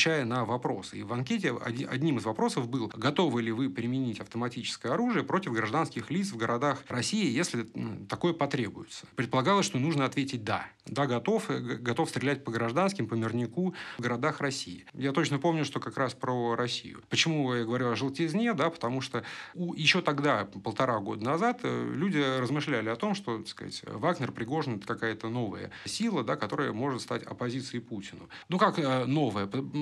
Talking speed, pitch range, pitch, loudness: 165 wpm, 115-155 Hz, 130 Hz, -30 LUFS